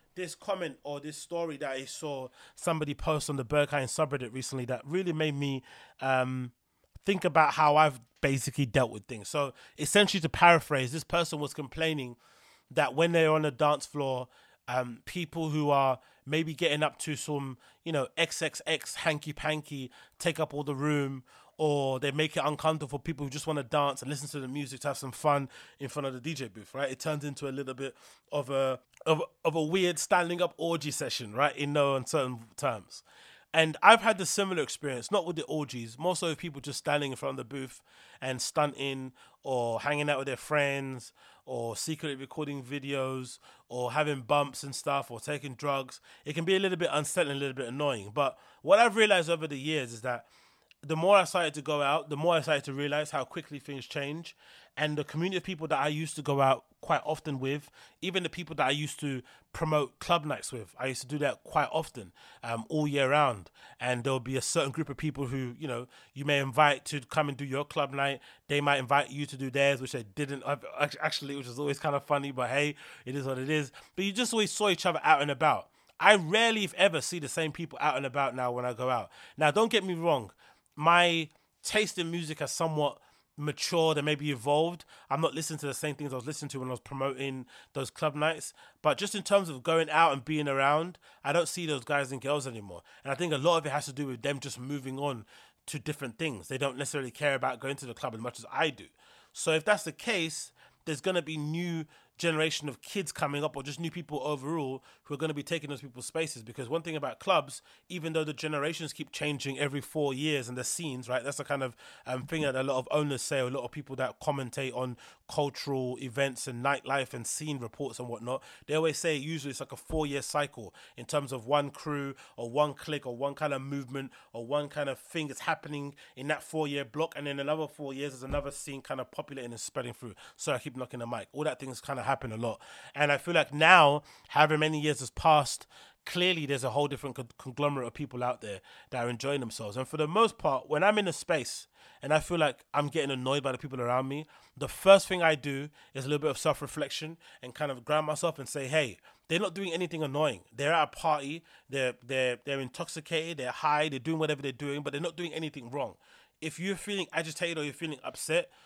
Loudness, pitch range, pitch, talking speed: -31 LUFS, 135-155 Hz, 145 Hz, 235 wpm